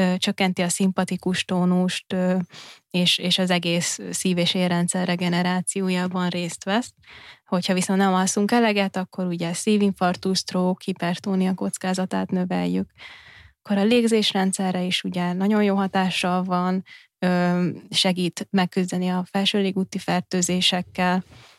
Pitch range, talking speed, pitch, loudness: 180-190 Hz, 115 wpm, 185 Hz, -22 LUFS